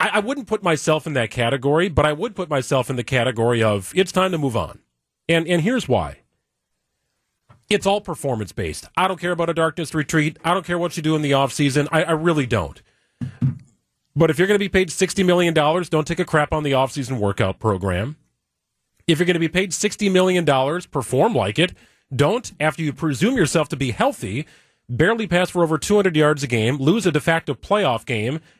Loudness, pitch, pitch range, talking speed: -20 LUFS, 155 Hz, 135-180 Hz, 210 wpm